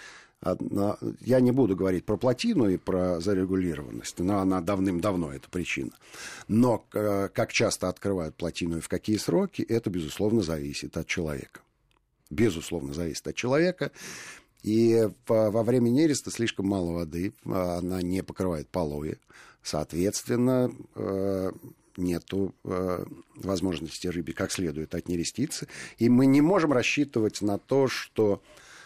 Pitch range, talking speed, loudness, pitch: 85-115 Hz, 120 wpm, -27 LUFS, 95 Hz